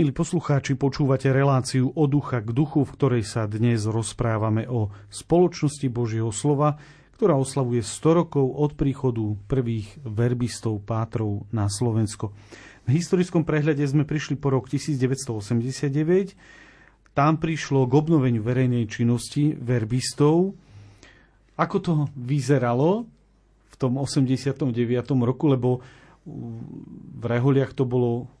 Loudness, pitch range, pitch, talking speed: -24 LUFS, 115-145 Hz, 130 Hz, 115 wpm